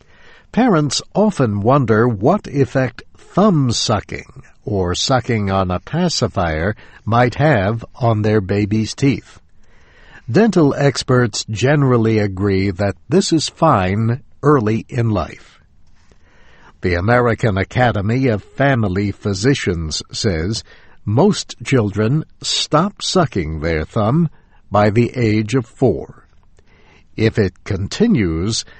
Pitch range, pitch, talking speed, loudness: 100-130 Hz, 110 Hz, 105 wpm, -17 LUFS